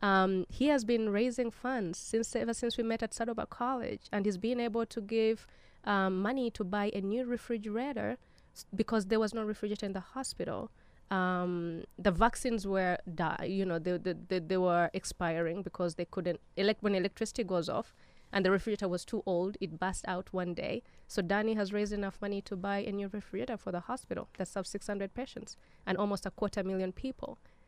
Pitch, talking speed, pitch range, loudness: 205 Hz, 200 wpm, 185-230 Hz, -34 LUFS